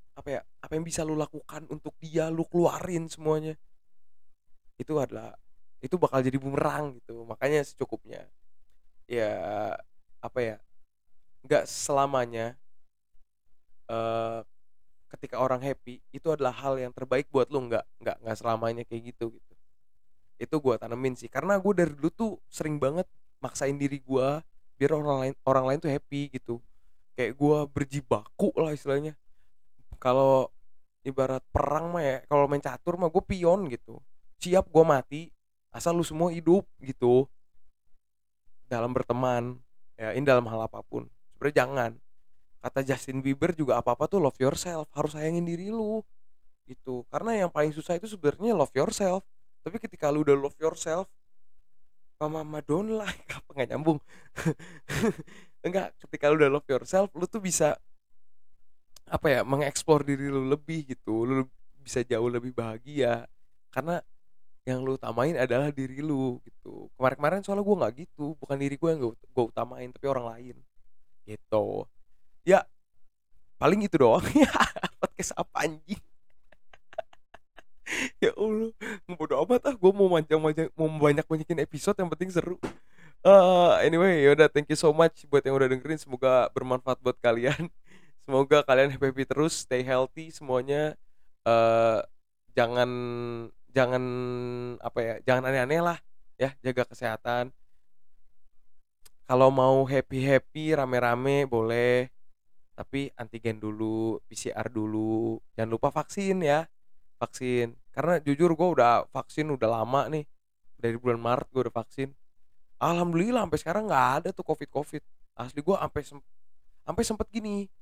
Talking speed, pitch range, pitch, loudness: 145 wpm, 120-155 Hz, 135 Hz, -28 LUFS